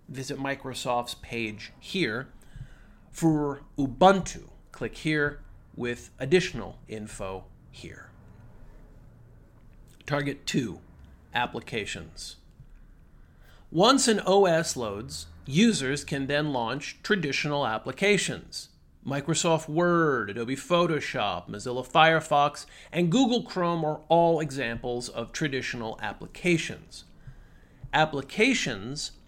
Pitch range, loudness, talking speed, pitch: 125-170 Hz, -27 LUFS, 85 wpm, 145 Hz